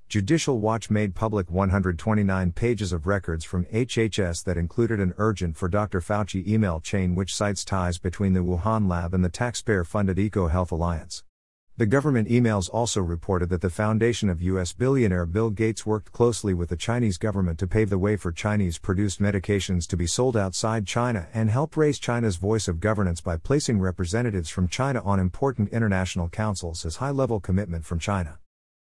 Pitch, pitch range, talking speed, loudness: 100 Hz, 90-110 Hz, 175 wpm, -25 LUFS